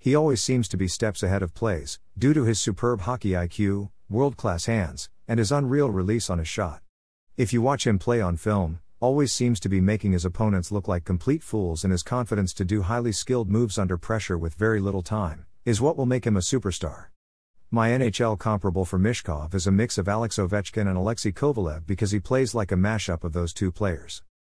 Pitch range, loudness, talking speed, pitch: 90-115 Hz, -25 LUFS, 215 wpm, 105 Hz